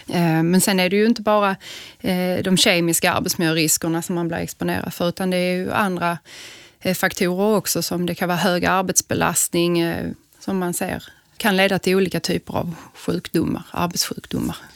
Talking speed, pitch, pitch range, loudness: 165 wpm, 180 Hz, 170-190 Hz, -20 LUFS